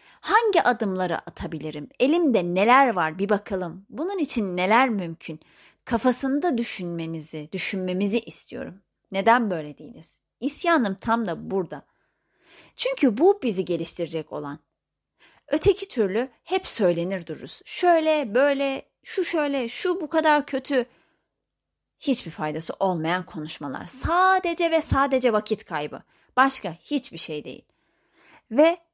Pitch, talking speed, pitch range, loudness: 225 Hz, 115 wpm, 175-290 Hz, -23 LUFS